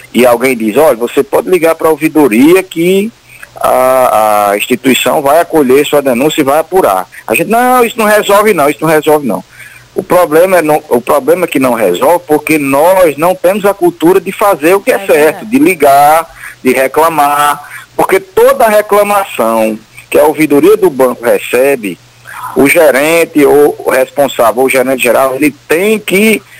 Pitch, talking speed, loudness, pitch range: 155 Hz, 175 wpm, -8 LUFS, 140-200 Hz